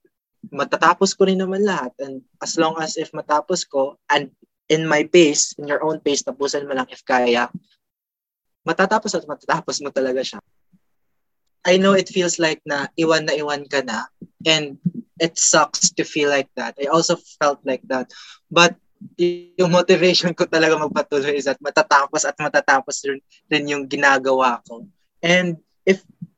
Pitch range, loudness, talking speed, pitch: 140-180 Hz, -19 LUFS, 160 wpm, 155 Hz